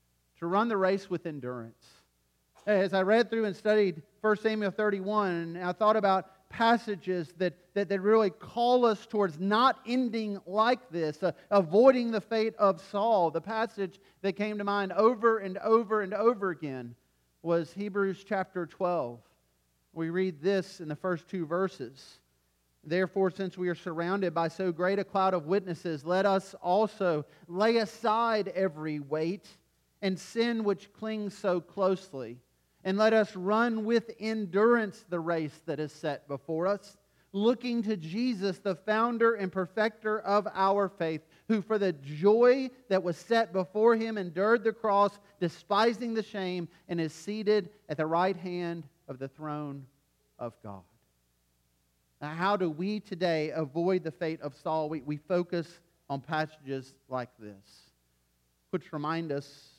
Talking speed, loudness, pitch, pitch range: 155 wpm, -30 LUFS, 190 Hz, 160-210 Hz